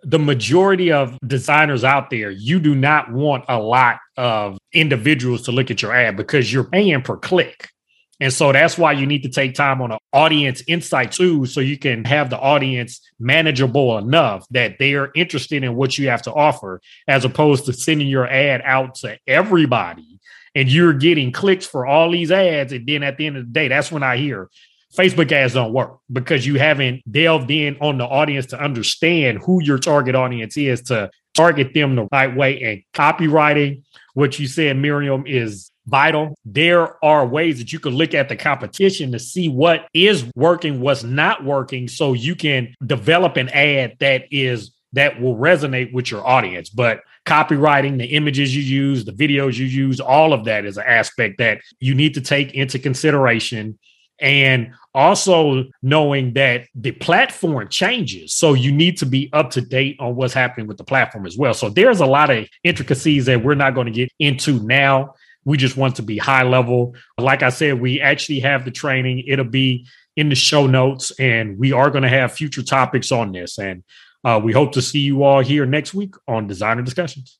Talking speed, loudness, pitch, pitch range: 200 wpm, -16 LUFS, 135 Hz, 125-150 Hz